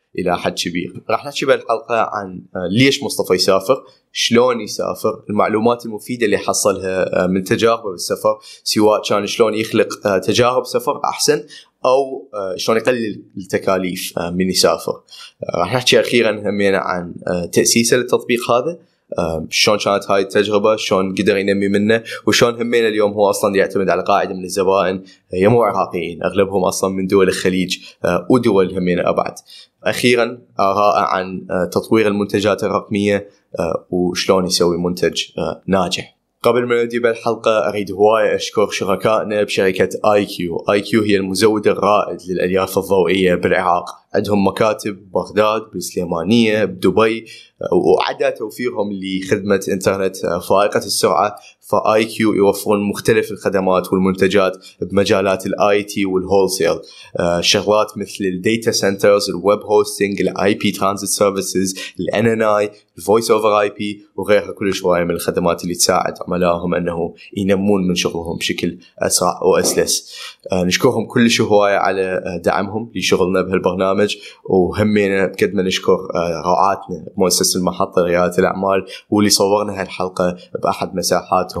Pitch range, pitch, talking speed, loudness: 95-110 Hz, 100 Hz, 125 wpm, -16 LUFS